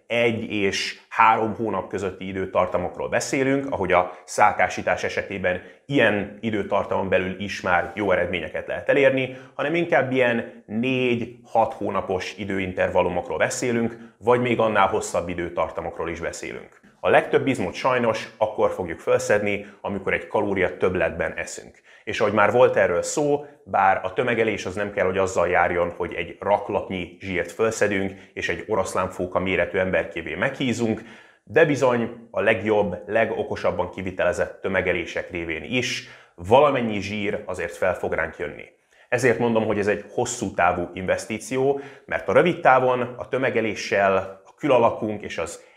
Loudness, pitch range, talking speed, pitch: -23 LUFS, 100-125 Hz, 140 wpm, 115 Hz